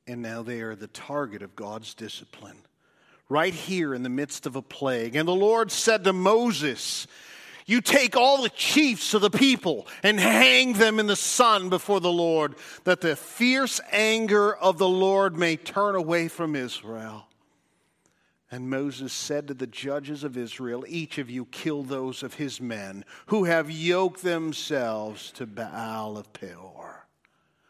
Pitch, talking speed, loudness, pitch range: 160 Hz, 165 wpm, -24 LUFS, 130-200 Hz